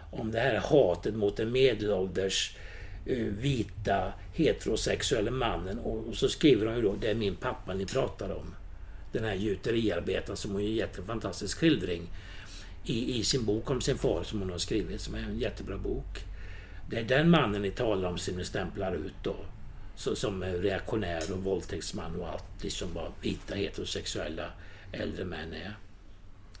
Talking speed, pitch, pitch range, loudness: 170 wpm, 95 Hz, 90-105 Hz, -31 LUFS